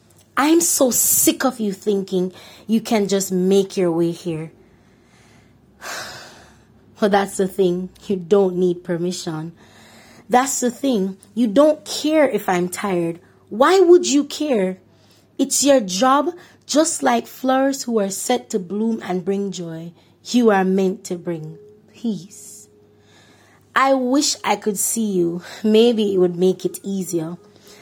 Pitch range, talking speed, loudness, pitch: 180-245 Hz, 140 wpm, -19 LUFS, 200 Hz